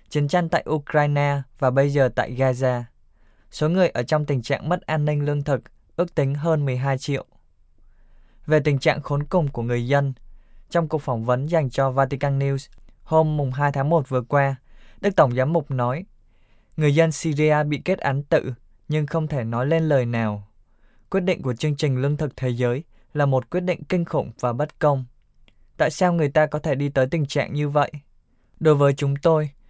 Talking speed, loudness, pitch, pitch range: 205 wpm, -22 LUFS, 145 Hz, 130-155 Hz